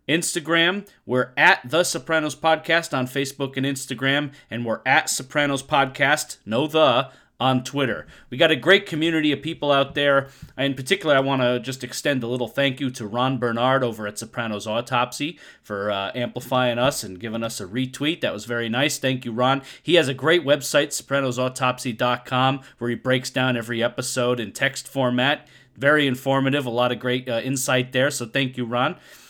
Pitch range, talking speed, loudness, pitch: 125-145 Hz, 185 wpm, -22 LUFS, 130 Hz